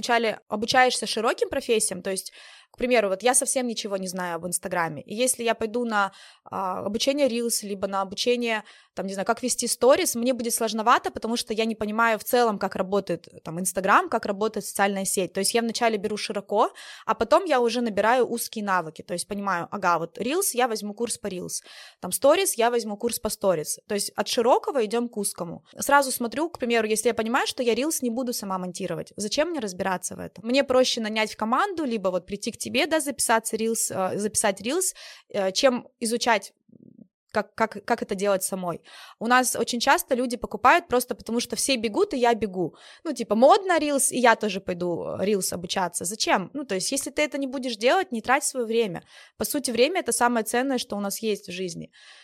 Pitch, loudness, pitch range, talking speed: 230 Hz, -24 LUFS, 200-250 Hz, 210 wpm